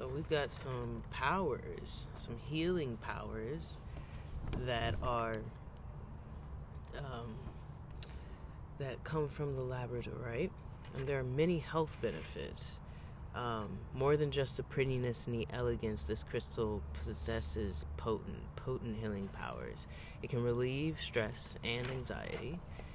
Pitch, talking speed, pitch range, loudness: 120 Hz, 120 wpm, 105-135 Hz, -40 LUFS